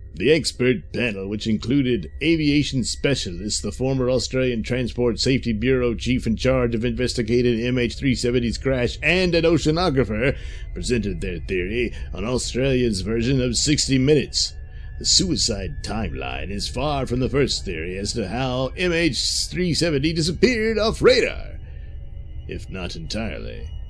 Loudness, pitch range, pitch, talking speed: -21 LUFS, 105-135 Hz, 125 Hz, 130 wpm